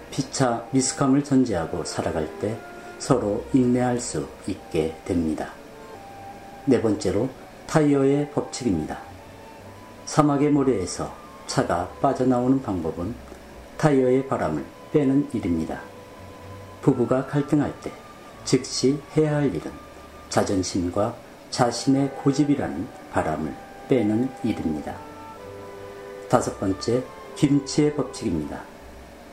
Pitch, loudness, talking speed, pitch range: 125 Hz, -24 LUFS, 235 characters per minute, 100-140 Hz